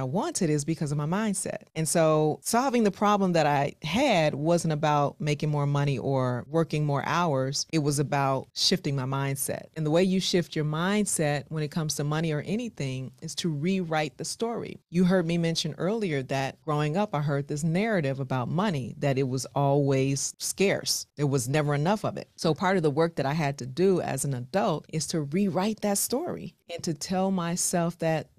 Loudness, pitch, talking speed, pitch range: -27 LUFS, 160 Hz, 205 wpm, 145-185 Hz